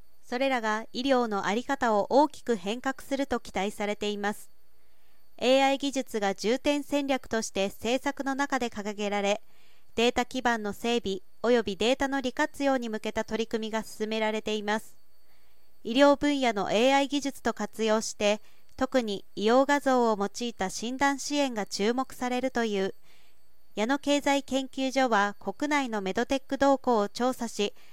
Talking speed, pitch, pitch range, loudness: 310 characters per minute, 235 Hz, 210-270 Hz, -28 LUFS